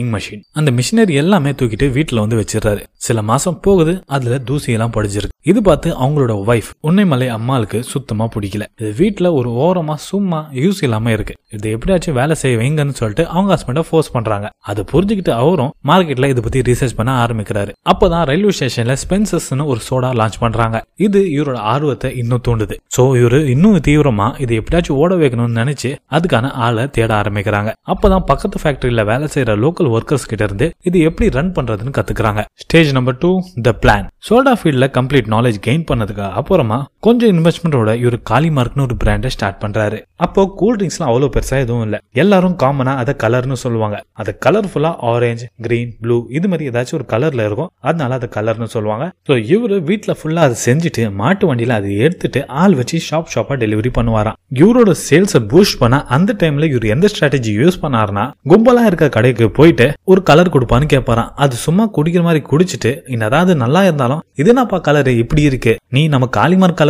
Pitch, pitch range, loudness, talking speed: 135 Hz, 115-165 Hz, -14 LUFS, 155 wpm